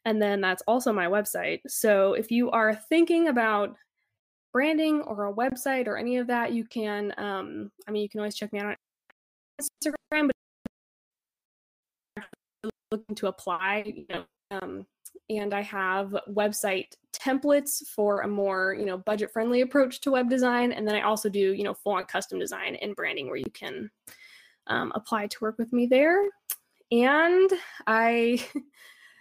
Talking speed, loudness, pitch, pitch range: 165 wpm, -27 LUFS, 220 Hz, 205-265 Hz